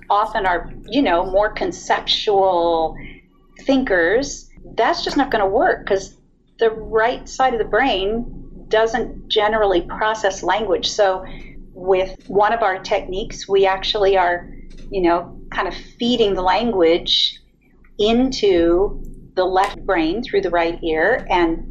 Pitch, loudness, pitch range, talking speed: 195 Hz, -18 LUFS, 175-220 Hz, 135 wpm